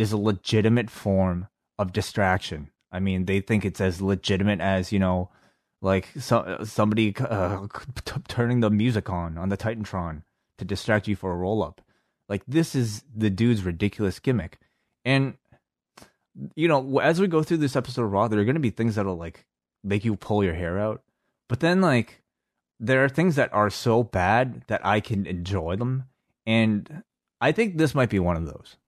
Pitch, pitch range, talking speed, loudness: 105 Hz, 95-120 Hz, 185 wpm, -25 LUFS